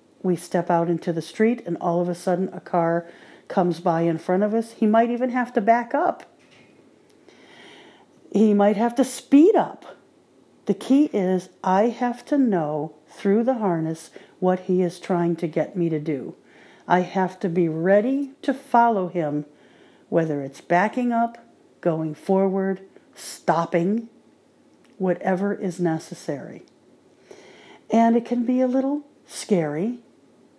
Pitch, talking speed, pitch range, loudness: 190 Hz, 150 wpm, 170-235 Hz, -22 LUFS